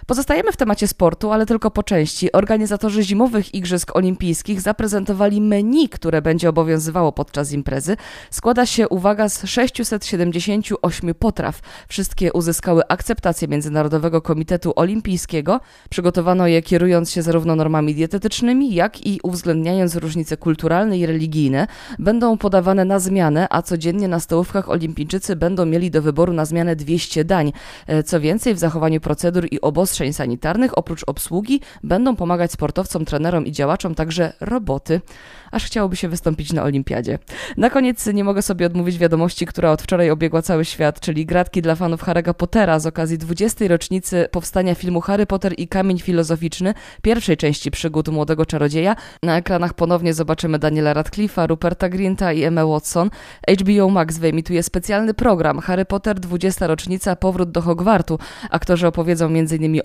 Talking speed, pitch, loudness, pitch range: 150 wpm, 175 Hz, -18 LUFS, 160-200 Hz